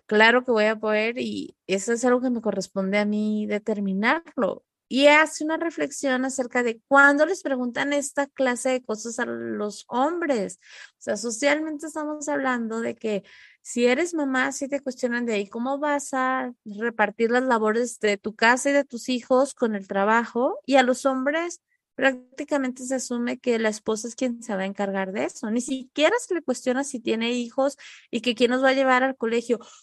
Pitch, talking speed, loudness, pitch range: 250 Hz, 195 wpm, -24 LUFS, 225-275 Hz